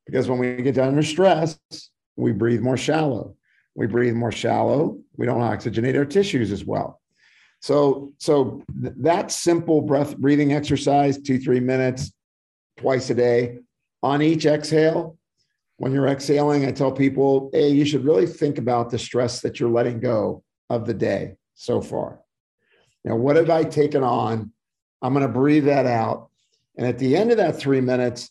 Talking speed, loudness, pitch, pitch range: 175 wpm, -21 LUFS, 135 Hz, 120-150 Hz